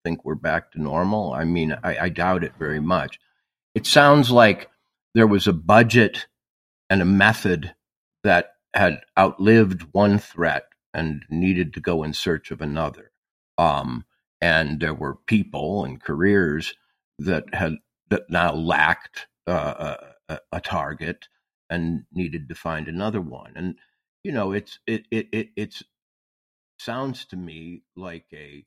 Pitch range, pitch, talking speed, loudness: 80-105 Hz, 90 Hz, 150 wpm, -21 LUFS